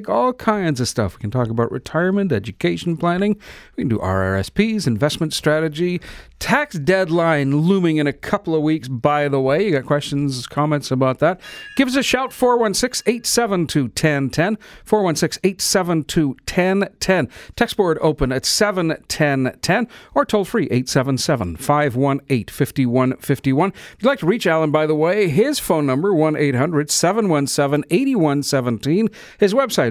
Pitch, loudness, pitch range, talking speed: 155 Hz, -19 LUFS, 140-200 Hz, 145 wpm